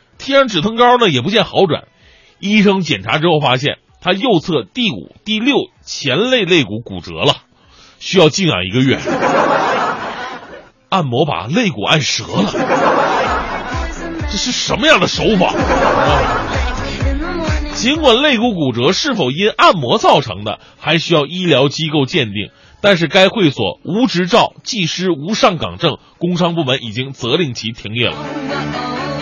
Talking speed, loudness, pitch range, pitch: 220 characters per minute, -14 LUFS, 135-210 Hz, 170 Hz